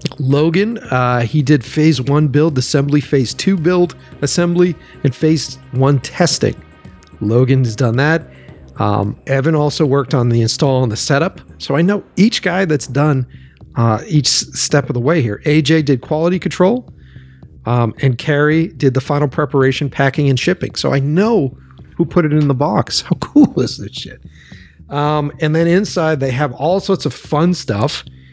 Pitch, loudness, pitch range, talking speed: 145 Hz, -15 LUFS, 130-160 Hz, 175 wpm